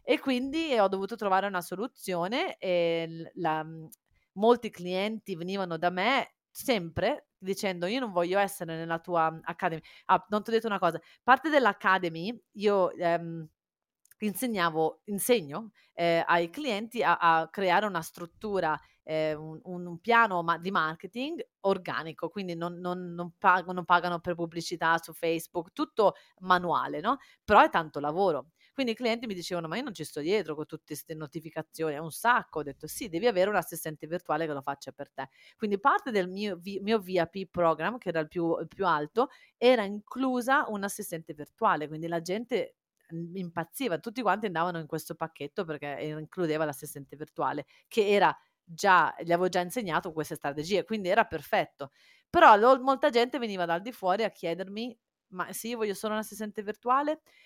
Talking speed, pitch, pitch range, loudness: 170 wpm, 180 Hz, 165-215 Hz, -29 LUFS